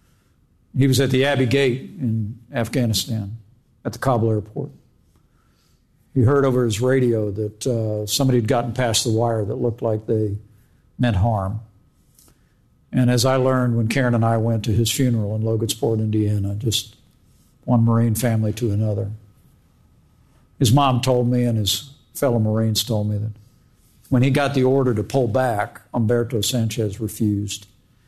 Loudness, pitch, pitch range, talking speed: -20 LUFS, 115 Hz, 110-125 Hz, 160 wpm